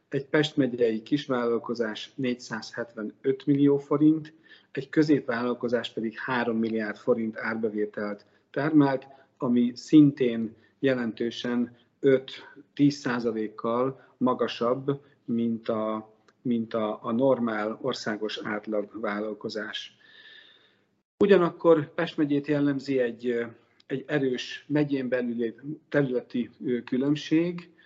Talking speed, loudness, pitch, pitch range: 90 wpm, -27 LUFS, 125 Hz, 115-145 Hz